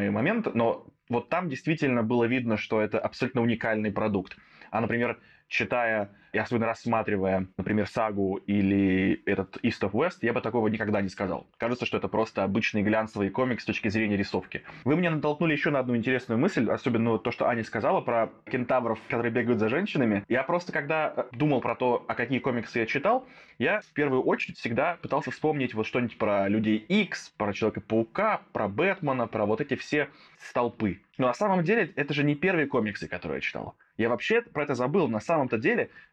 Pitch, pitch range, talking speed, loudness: 120 Hz, 110-140 Hz, 190 wpm, -27 LUFS